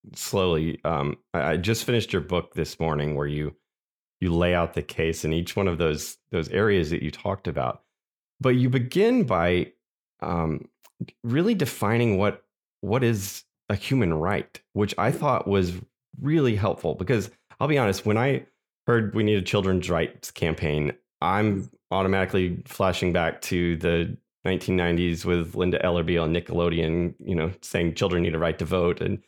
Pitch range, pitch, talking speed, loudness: 85-105 Hz, 90 Hz, 165 wpm, -25 LUFS